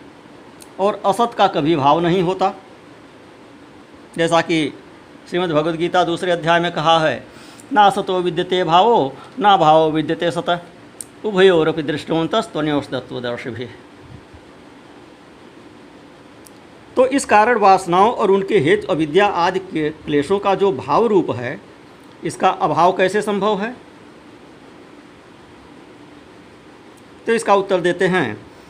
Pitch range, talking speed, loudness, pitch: 160-195 Hz, 115 wpm, -17 LUFS, 175 Hz